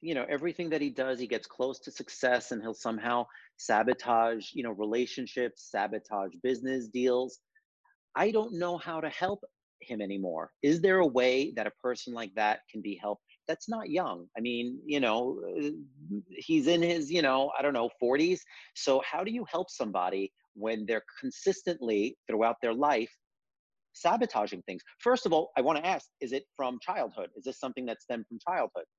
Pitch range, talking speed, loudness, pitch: 115-170 Hz, 185 wpm, -31 LUFS, 130 Hz